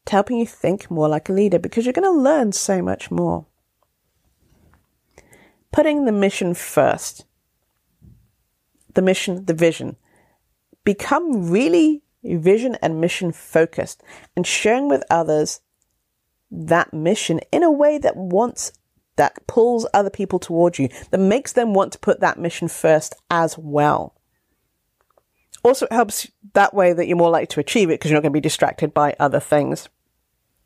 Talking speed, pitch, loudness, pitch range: 155 wpm, 185 Hz, -19 LUFS, 160-230 Hz